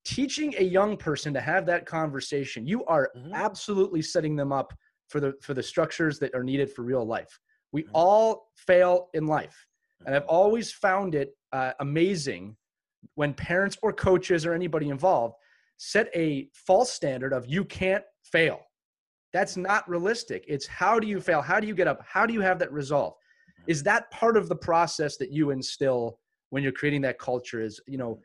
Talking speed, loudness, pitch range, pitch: 185 wpm, -26 LUFS, 140-190 Hz, 160 Hz